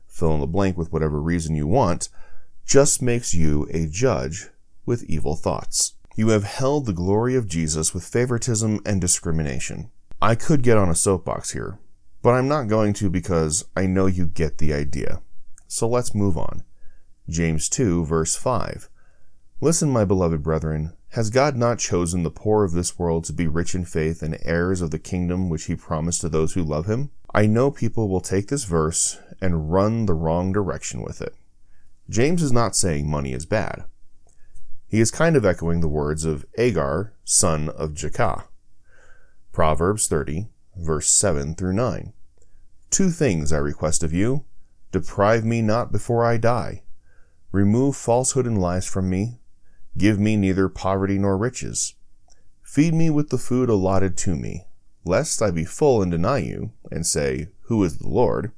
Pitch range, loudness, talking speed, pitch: 80-110 Hz, -22 LUFS, 175 wpm, 95 Hz